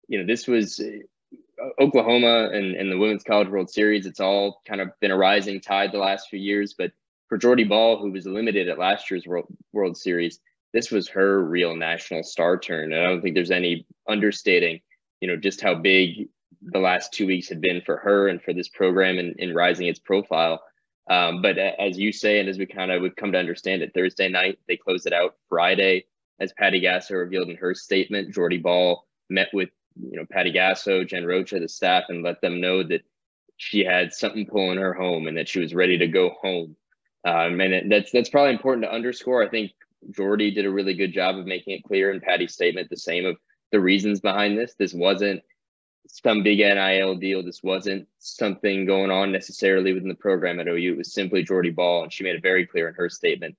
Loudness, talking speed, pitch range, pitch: -22 LUFS, 220 wpm, 90-105 Hz, 95 Hz